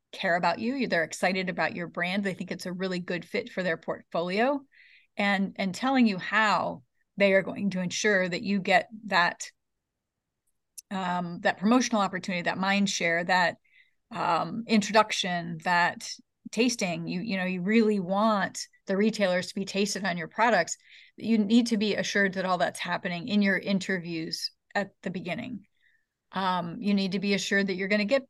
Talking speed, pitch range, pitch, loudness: 180 wpm, 185-220 Hz, 195 Hz, -27 LUFS